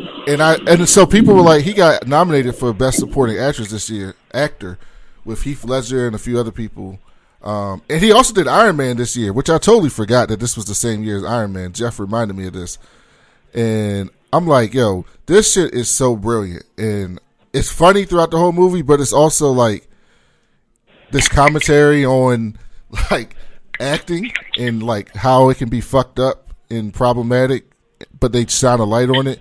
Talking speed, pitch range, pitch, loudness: 190 wpm, 110-145 Hz, 125 Hz, -15 LUFS